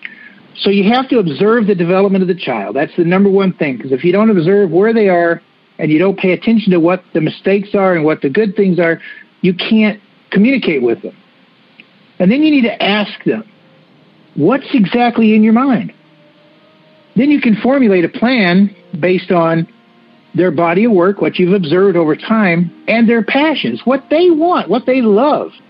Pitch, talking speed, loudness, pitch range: 195 Hz, 190 wpm, -12 LUFS, 175-225 Hz